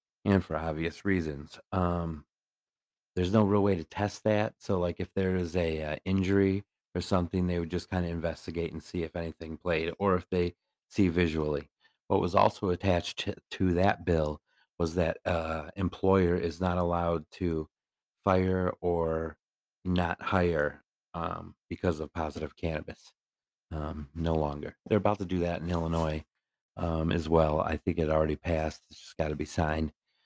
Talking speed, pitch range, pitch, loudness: 175 wpm, 80-90 Hz, 85 Hz, -30 LUFS